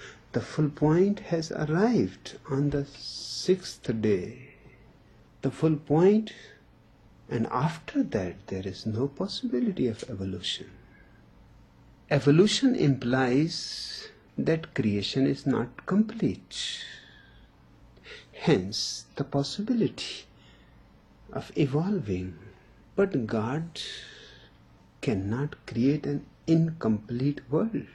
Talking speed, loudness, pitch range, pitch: 85 wpm, -28 LUFS, 120-180 Hz, 145 Hz